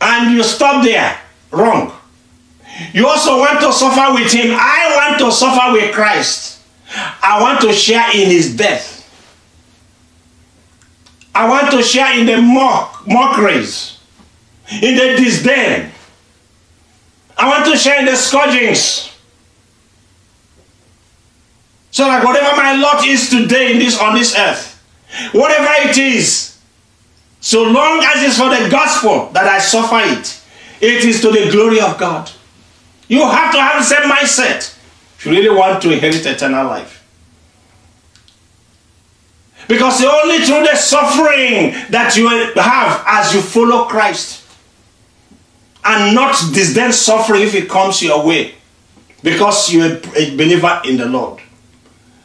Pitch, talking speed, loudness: 215 Hz, 140 wpm, -10 LUFS